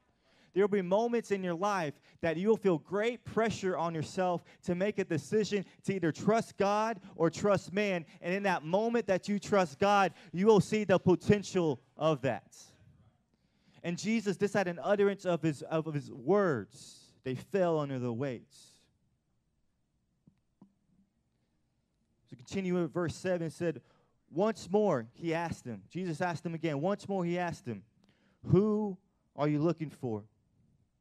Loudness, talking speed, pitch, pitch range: -32 LUFS, 160 wpm, 180 Hz, 160-200 Hz